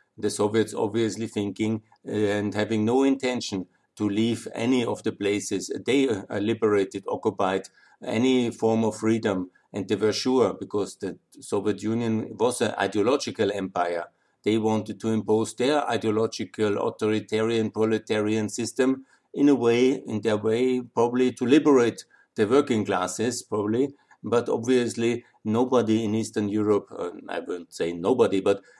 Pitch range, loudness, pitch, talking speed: 105-115 Hz, -25 LUFS, 110 Hz, 140 wpm